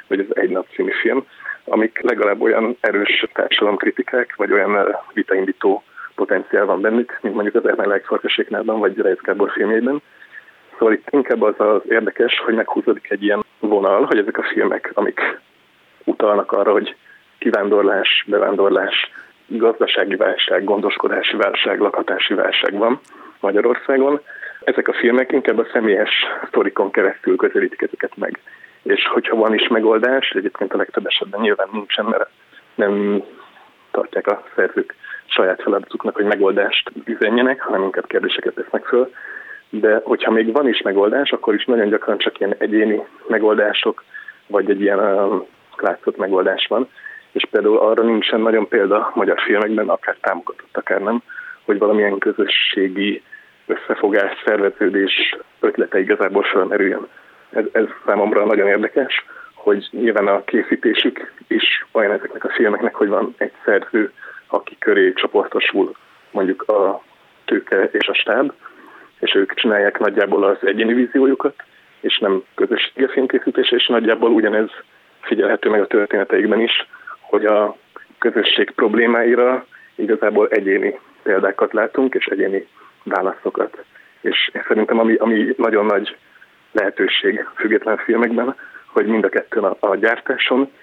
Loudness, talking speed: -17 LUFS, 135 wpm